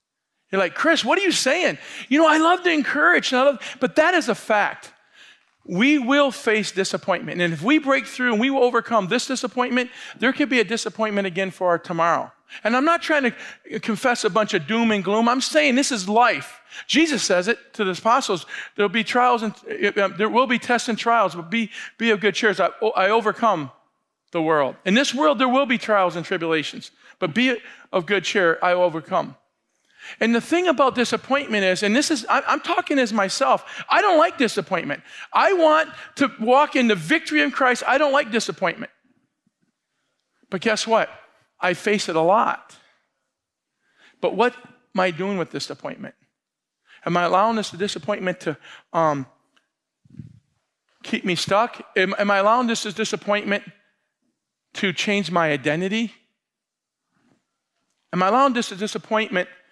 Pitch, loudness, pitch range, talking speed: 225 Hz, -20 LUFS, 195-265 Hz, 175 wpm